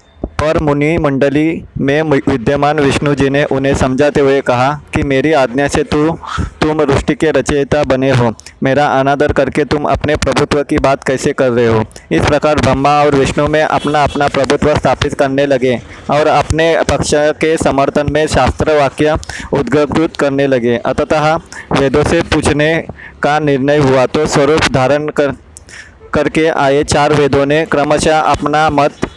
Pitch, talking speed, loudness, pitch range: 145 Hz, 160 wpm, -12 LUFS, 135-150 Hz